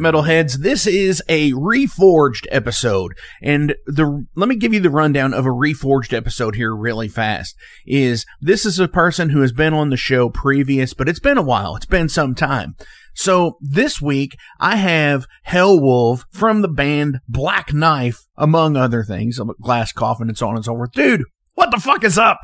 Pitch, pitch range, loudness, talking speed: 140 Hz, 120-160 Hz, -16 LUFS, 190 wpm